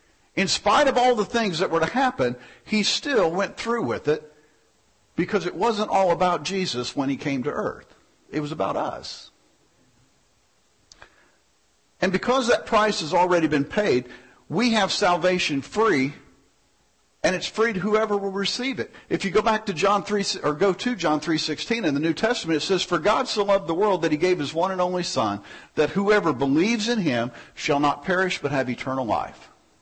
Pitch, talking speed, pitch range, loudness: 185 Hz, 190 wpm, 150-210 Hz, -23 LUFS